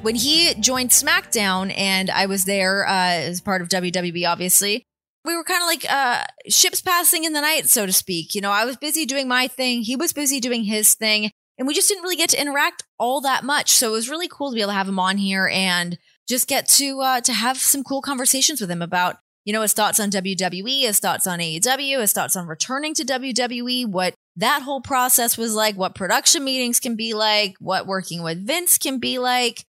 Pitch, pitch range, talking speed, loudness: 235 Hz, 195-275 Hz, 230 wpm, -19 LUFS